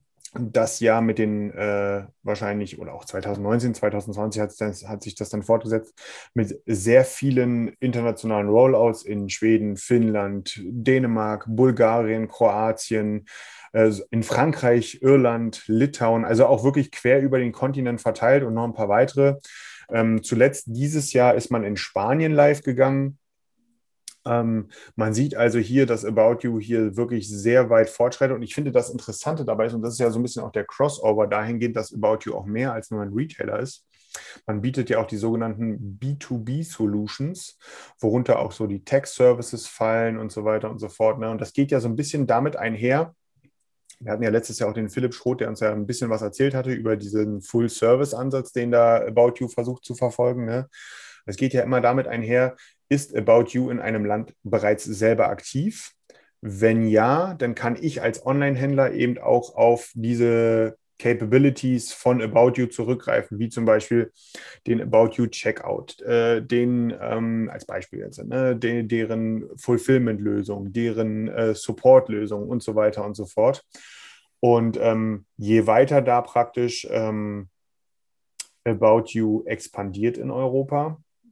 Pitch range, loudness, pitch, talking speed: 110-125 Hz, -22 LUFS, 115 Hz, 165 wpm